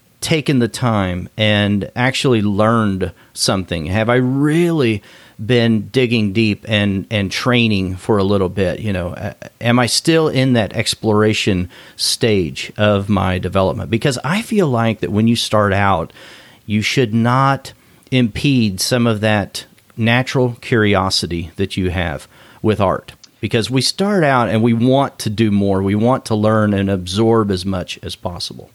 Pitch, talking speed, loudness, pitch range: 110 Hz, 155 wpm, -16 LUFS, 100-125 Hz